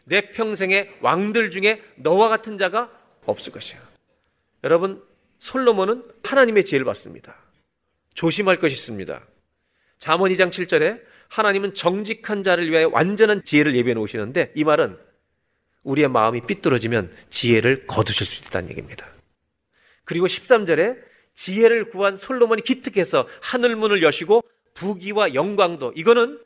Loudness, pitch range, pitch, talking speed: -20 LUFS, 165-225 Hz, 195 Hz, 315 characters per minute